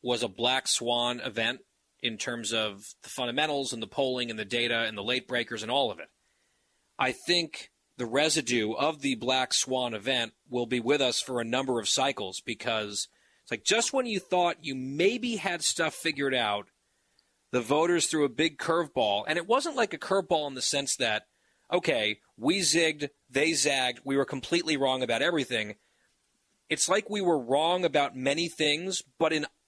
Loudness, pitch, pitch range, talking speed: -28 LUFS, 135 Hz, 120-165 Hz, 185 wpm